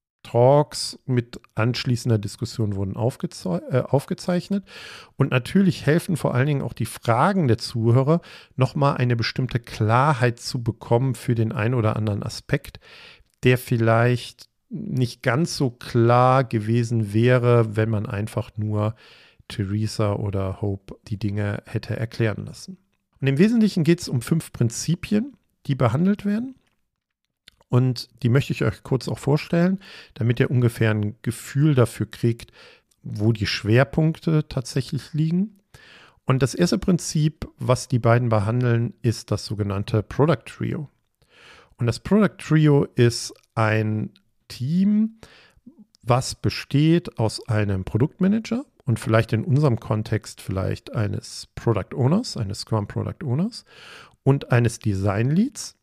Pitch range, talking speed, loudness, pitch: 110-150 Hz, 135 wpm, -22 LUFS, 120 Hz